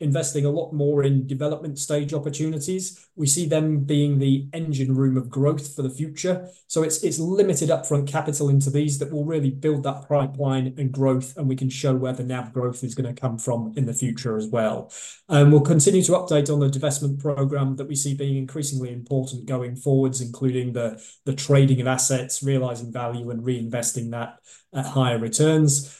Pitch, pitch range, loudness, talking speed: 140 Hz, 130-150 Hz, -23 LUFS, 195 wpm